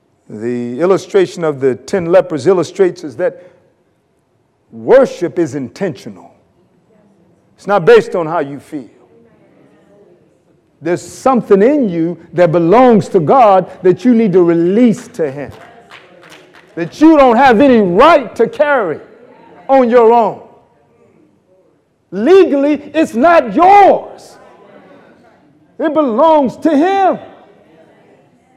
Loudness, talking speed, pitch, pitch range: -11 LUFS, 110 wpm, 225 Hz, 175-295 Hz